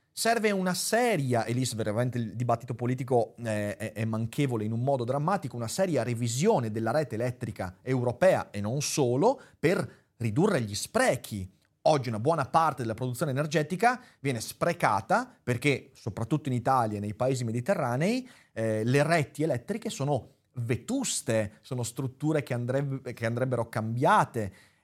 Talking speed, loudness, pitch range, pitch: 145 wpm, -29 LUFS, 115-155 Hz, 125 Hz